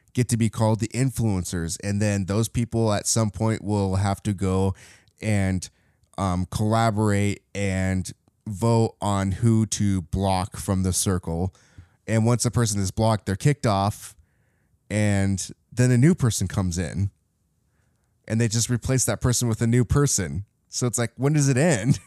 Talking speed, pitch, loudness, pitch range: 170 wpm, 105 Hz, -23 LUFS, 95-115 Hz